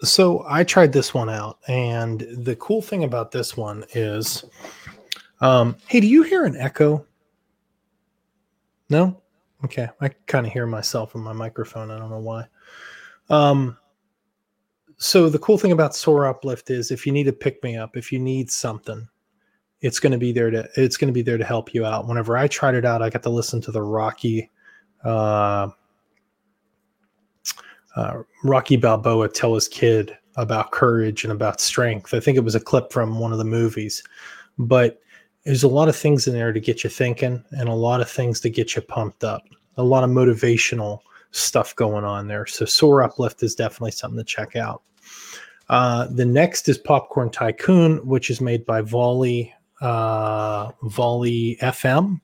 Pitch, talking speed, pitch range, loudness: 120 Hz, 180 wpm, 115-135 Hz, -20 LUFS